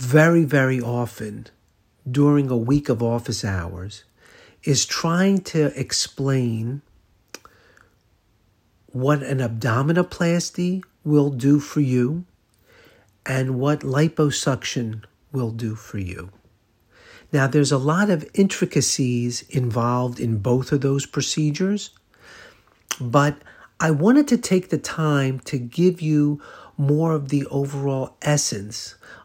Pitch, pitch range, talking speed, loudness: 135 Hz, 115-150 Hz, 110 wpm, -21 LUFS